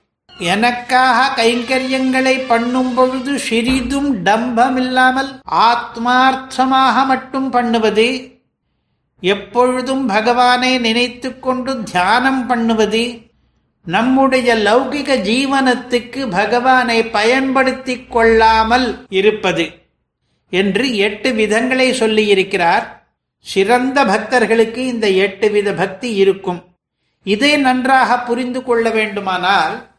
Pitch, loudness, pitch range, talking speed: 245 Hz, -14 LUFS, 220-260 Hz, 75 wpm